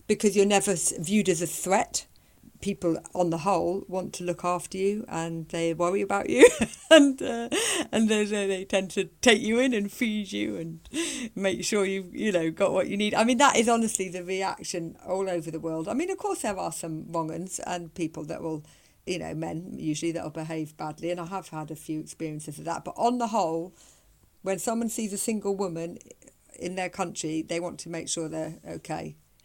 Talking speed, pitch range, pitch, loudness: 210 wpm, 165-210 Hz, 180 Hz, -27 LUFS